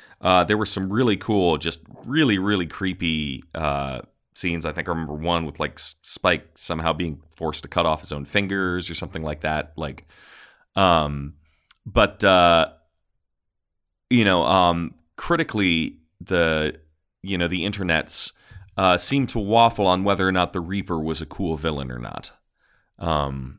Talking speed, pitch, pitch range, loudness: 160 wpm, 85 Hz, 75-95 Hz, -22 LUFS